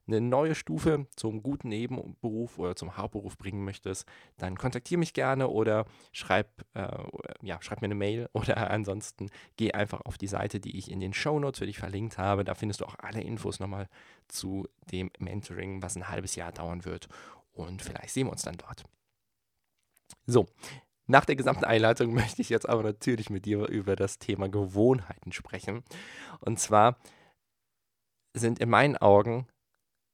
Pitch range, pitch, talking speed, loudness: 95-120 Hz, 105 Hz, 170 wpm, -30 LUFS